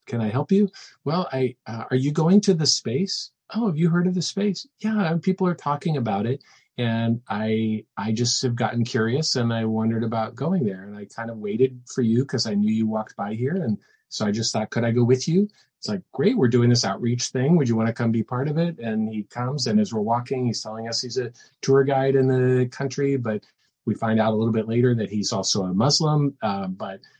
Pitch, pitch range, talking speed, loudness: 125 Hz, 110-145 Hz, 245 wpm, -23 LUFS